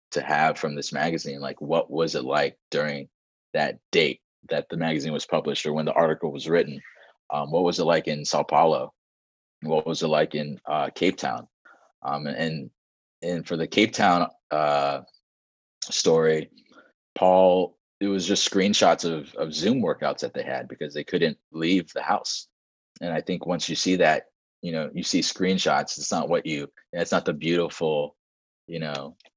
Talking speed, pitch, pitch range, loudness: 180 wpm, 75 Hz, 70-85 Hz, -25 LUFS